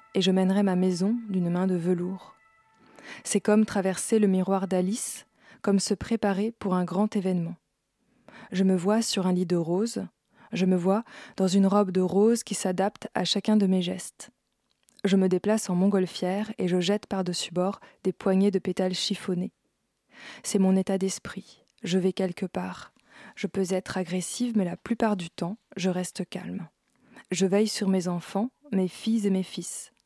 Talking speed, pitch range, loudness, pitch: 180 wpm, 185-210 Hz, -27 LUFS, 195 Hz